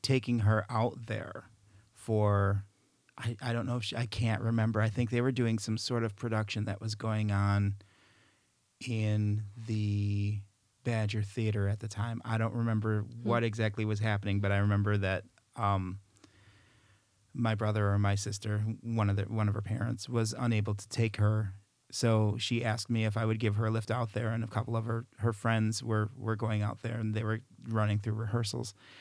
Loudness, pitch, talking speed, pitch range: -32 LUFS, 110 Hz, 195 wpm, 105-115 Hz